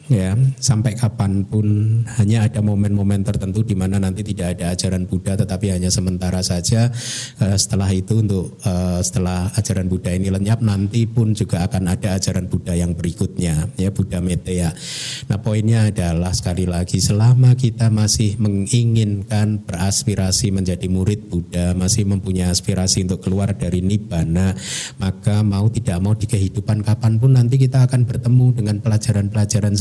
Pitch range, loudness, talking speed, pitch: 95-110 Hz, -18 LUFS, 145 wpm, 100 Hz